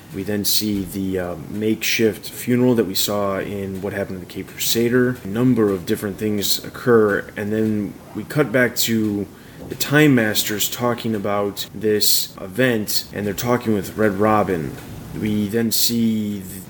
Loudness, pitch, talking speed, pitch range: -19 LUFS, 105 Hz, 165 wpm, 100-115 Hz